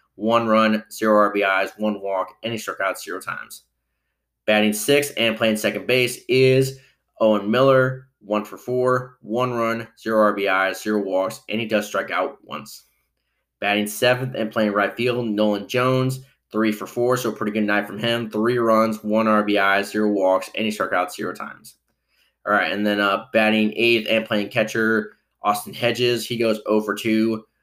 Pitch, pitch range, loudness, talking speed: 110 Hz, 105-115 Hz, -21 LUFS, 180 wpm